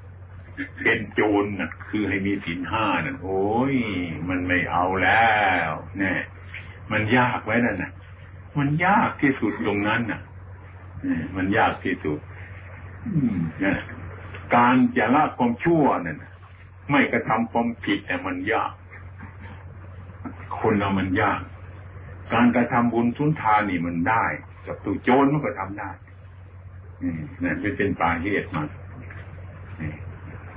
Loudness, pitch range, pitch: -23 LUFS, 95-105 Hz, 95 Hz